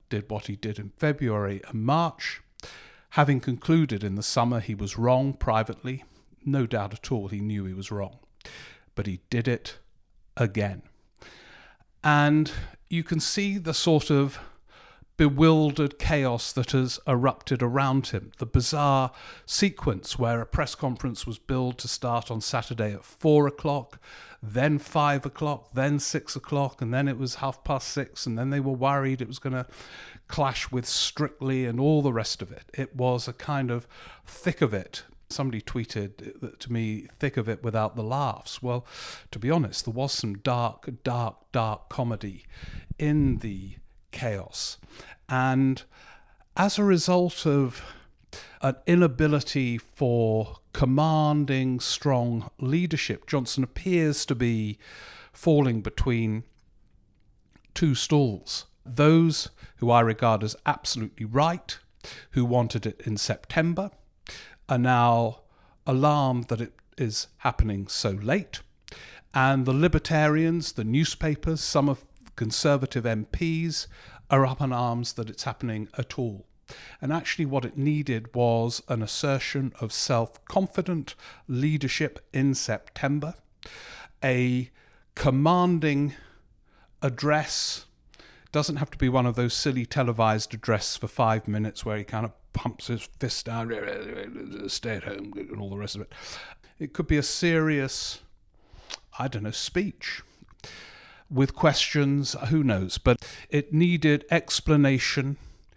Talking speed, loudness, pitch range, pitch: 140 wpm, -26 LUFS, 115-145 Hz, 130 Hz